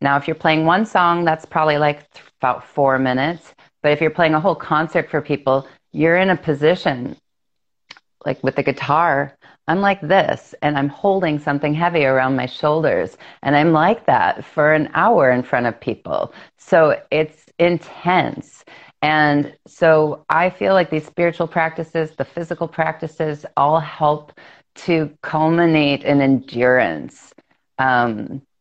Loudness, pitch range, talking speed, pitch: -18 LUFS, 145-170 Hz, 150 wpm, 155 Hz